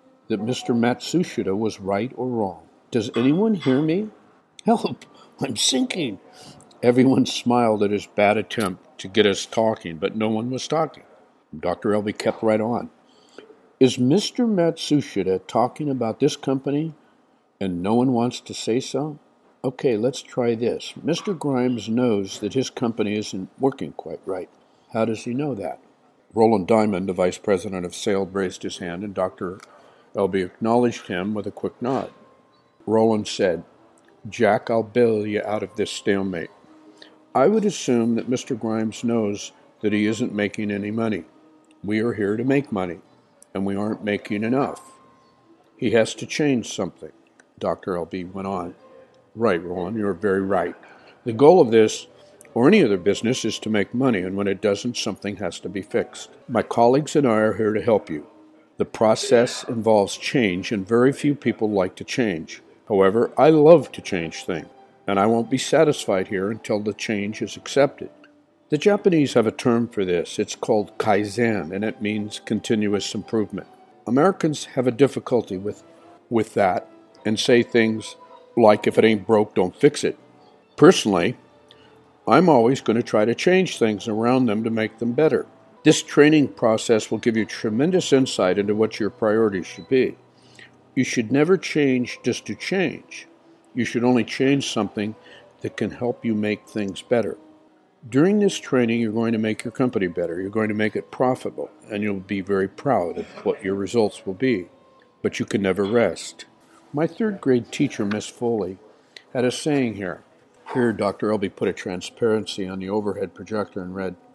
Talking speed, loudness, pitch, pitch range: 170 wpm, -22 LUFS, 110 Hz, 105-130 Hz